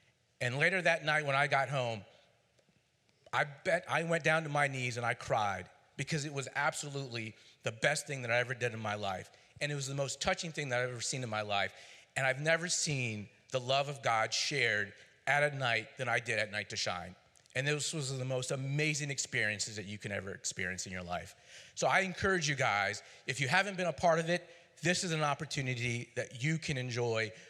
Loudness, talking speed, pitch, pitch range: -34 LUFS, 225 wpm, 130 Hz, 115-150 Hz